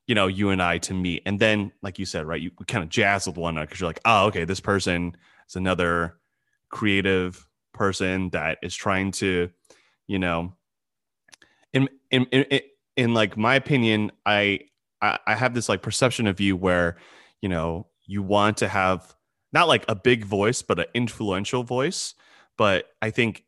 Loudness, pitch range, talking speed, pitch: -24 LUFS, 90-110 Hz, 180 wpm, 100 Hz